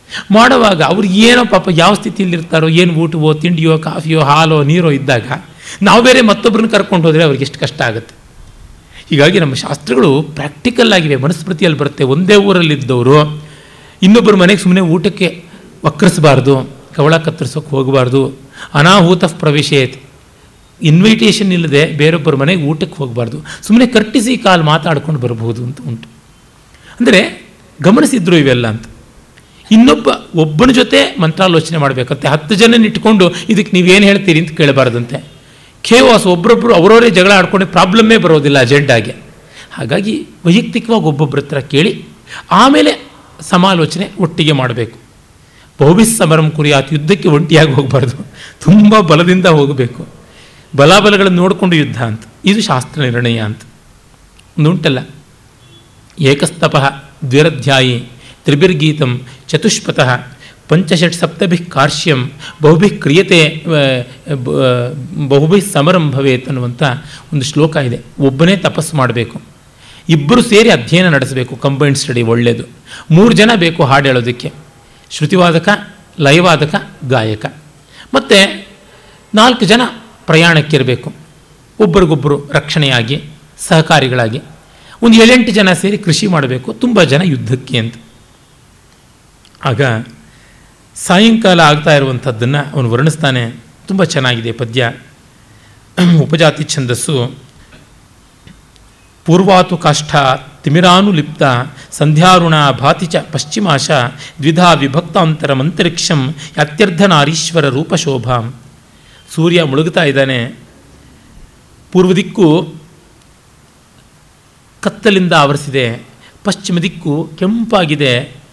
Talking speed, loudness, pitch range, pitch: 95 wpm, -10 LUFS, 135-185 Hz, 155 Hz